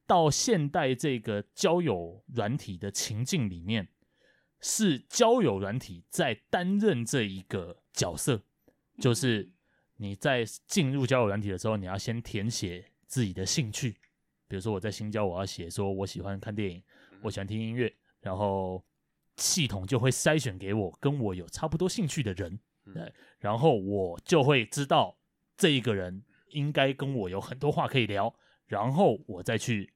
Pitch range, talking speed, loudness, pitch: 100-140 Hz, 240 characters per minute, -30 LUFS, 115 Hz